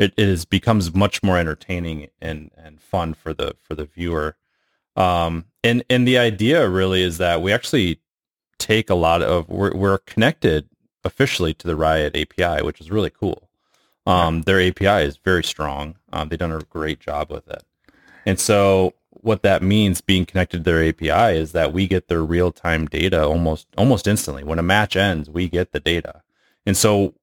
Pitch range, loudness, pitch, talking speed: 80-100 Hz, -19 LUFS, 90 Hz, 185 wpm